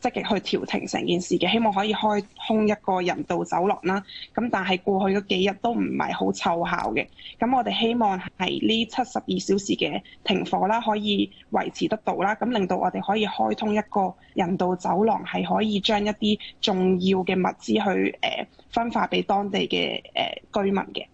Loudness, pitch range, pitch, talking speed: -24 LUFS, 185-215 Hz, 200 Hz, 285 characters per minute